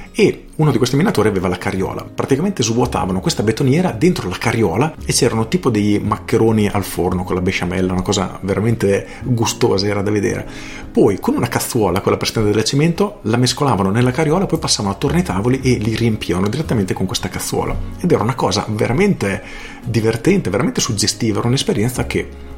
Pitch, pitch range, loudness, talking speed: 115 Hz, 100-130 Hz, -17 LUFS, 180 wpm